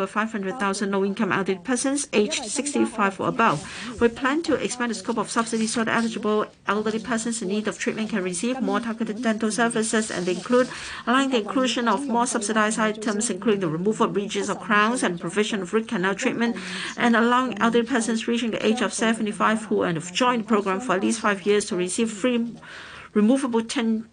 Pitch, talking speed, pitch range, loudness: 220 Hz, 195 wpm, 205-235 Hz, -23 LUFS